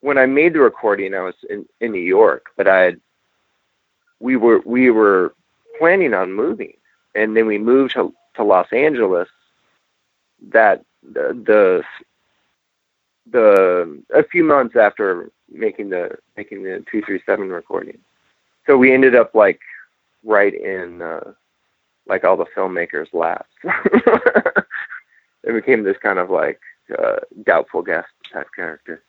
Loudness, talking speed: -16 LUFS, 140 wpm